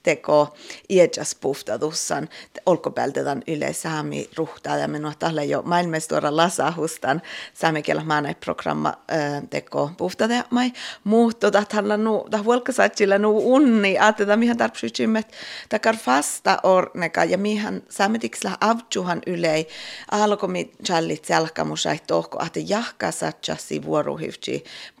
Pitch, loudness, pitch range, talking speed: 185 Hz, -22 LUFS, 150-215 Hz, 105 wpm